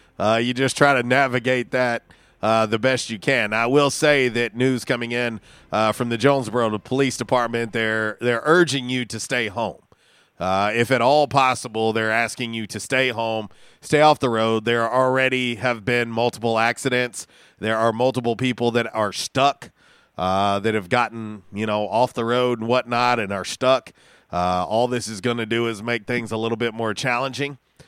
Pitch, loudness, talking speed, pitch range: 120 Hz, -21 LUFS, 190 wpm, 110-130 Hz